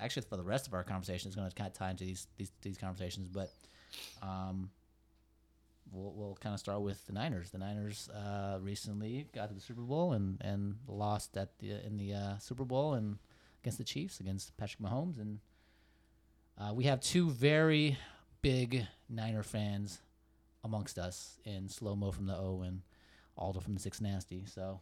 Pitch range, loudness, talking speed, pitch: 95-105 Hz, -39 LUFS, 185 wpm, 100 Hz